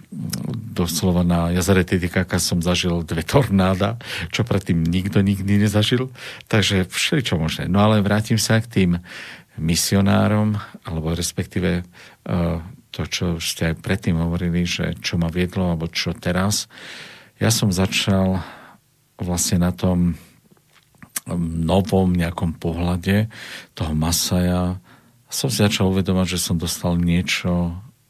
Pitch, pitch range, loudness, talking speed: 90 Hz, 85-105 Hz, -20 LUFS, 120 wpm